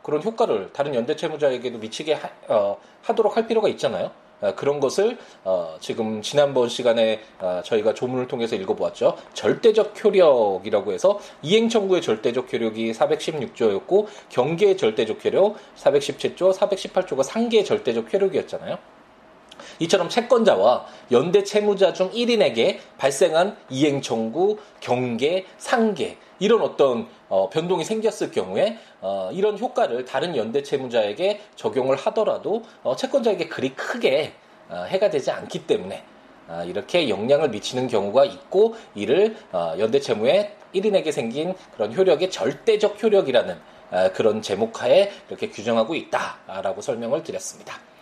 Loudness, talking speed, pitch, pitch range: -22 LUFS, 320 characters per minute, 195 Hz, 140-225 Hz